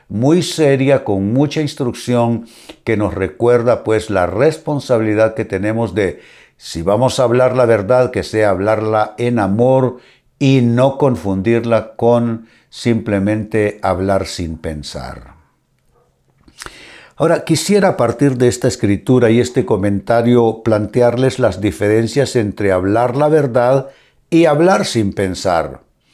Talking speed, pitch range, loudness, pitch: 125 wpm, 105-130 Hz, -15 LUFS, 115 Hz